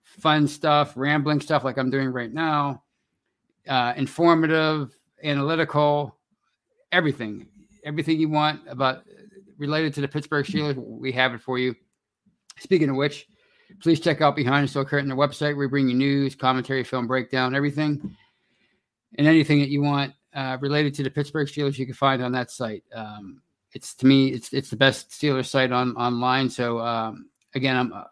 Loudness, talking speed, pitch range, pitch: -23 LUFS, 175 wpm, 130-150 Hz, 140 Hz